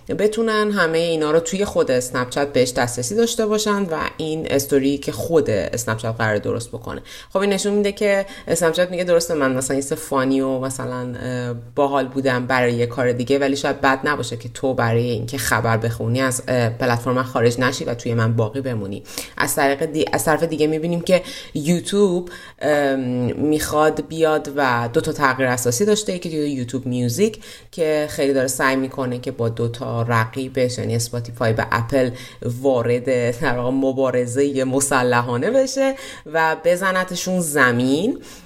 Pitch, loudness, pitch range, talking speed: 135 Hz, -20 LUFS, 125-160 Hz, 155 wpm